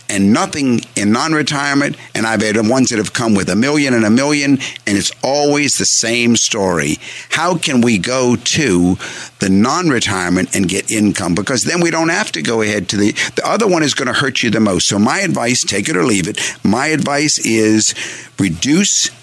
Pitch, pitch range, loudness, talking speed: 115 Hz, 105-140 Hz, -14 LUFS, 205 wpm